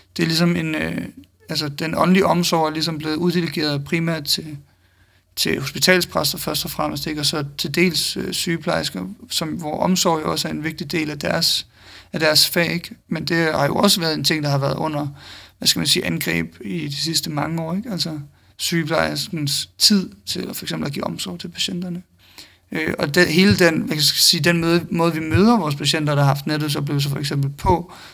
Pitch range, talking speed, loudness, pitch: 145-170 Hz, 220 wpm, -19 LUFS, 160 Hz